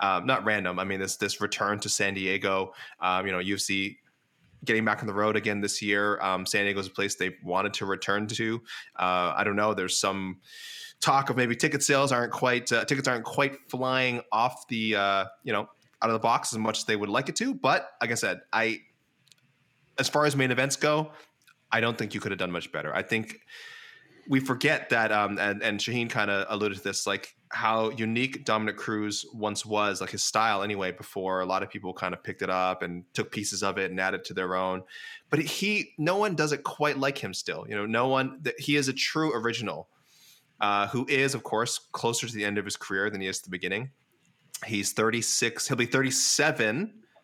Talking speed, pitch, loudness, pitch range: 225 wpm, 110 Hz, -27 LUFS, 100-135 Hz